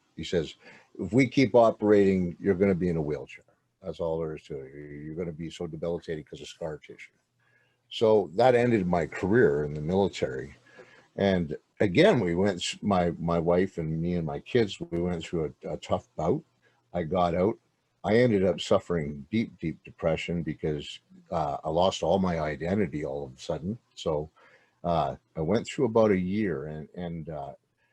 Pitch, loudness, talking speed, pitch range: 85 Hz, -27 LUFS, 190 wpm, 80-95 Hz